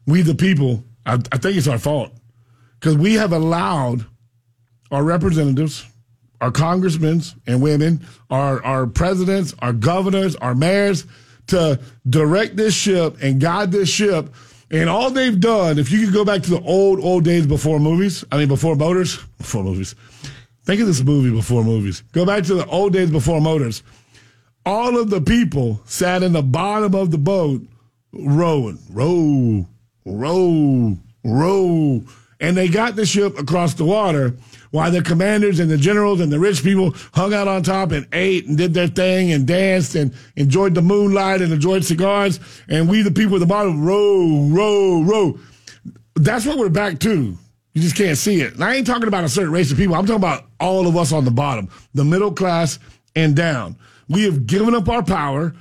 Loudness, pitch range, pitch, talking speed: -17 LUFS, 130-190 Hz, 160 Hz, 185 wpm